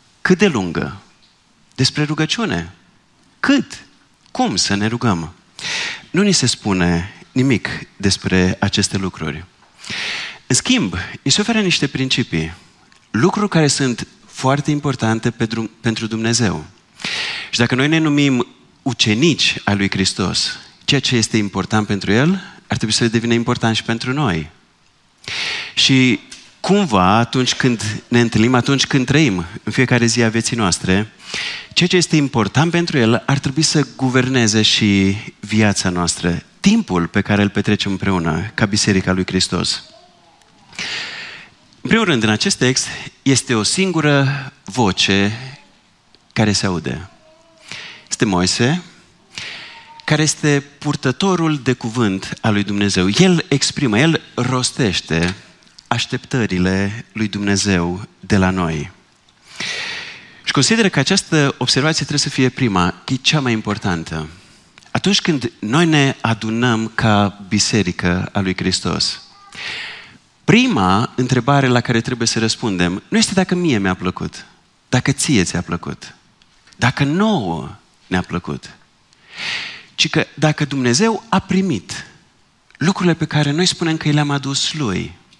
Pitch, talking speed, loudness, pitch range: 120 Hz, 130 wpm, -17 LUFS, 100-150 Hz